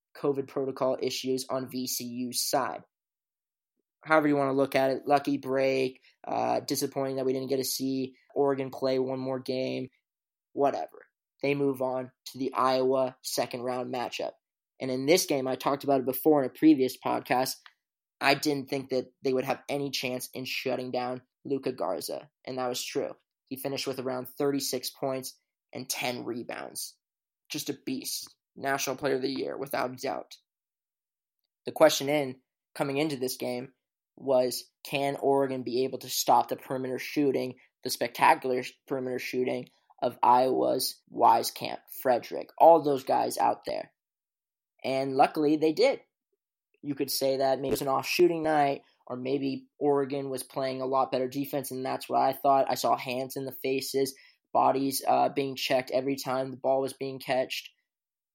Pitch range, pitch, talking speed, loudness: 130-140 Hz, 135 Hz, 170 wpm, -29 LUFS